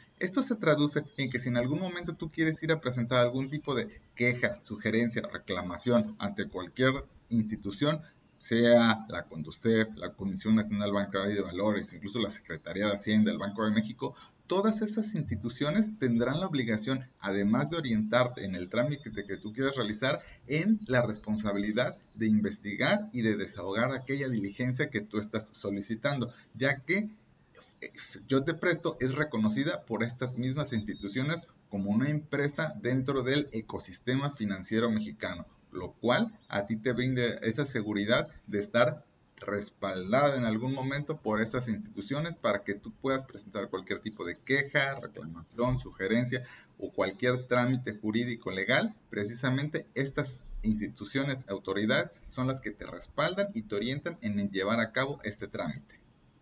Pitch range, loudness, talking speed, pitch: 105-140 Hz, -31 LUFS, 150 wpm, 120 Hz